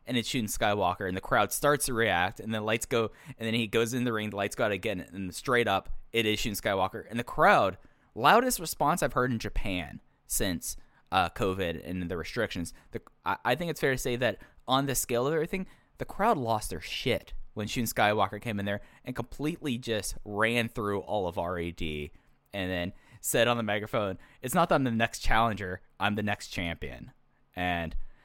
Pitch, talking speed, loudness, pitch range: 110 Hz, 210 wpm, -30 LUFS, 95-120 Hz